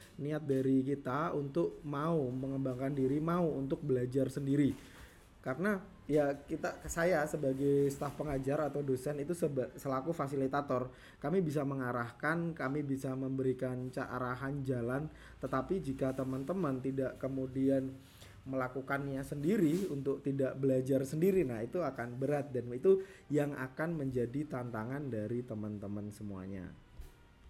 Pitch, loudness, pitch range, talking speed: 135 Hz, -36 LUFS, 130-145 Hz, 120 wpm